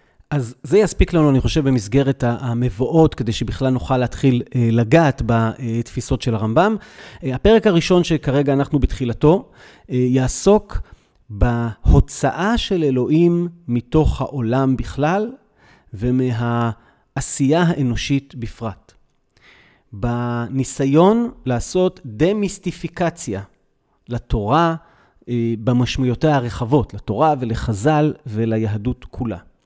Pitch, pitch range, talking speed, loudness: 130 Hz, 120-155 Hz, 85 wpm, -19 LUFS